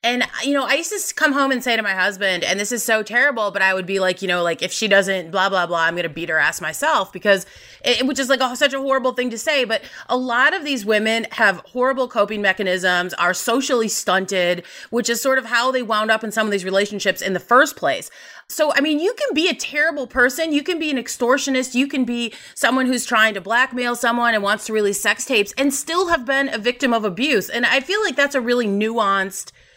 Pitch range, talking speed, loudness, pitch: 200-270 Hz, 255 wpm, -19 LUFS, 235 Hz